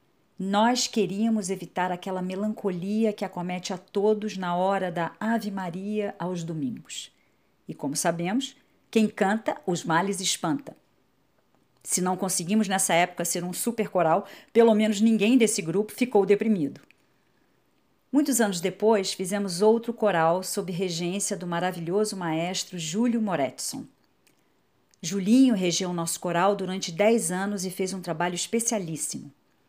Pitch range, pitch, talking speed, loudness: 180-215 Hz, 195 Hz, 130 wpm, -26 LUFS